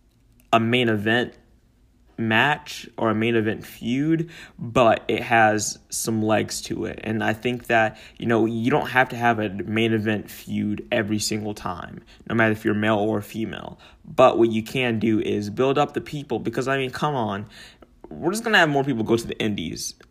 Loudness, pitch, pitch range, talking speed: -22 LUFS, 115 Hz, 110-120 Hz, 195 wpm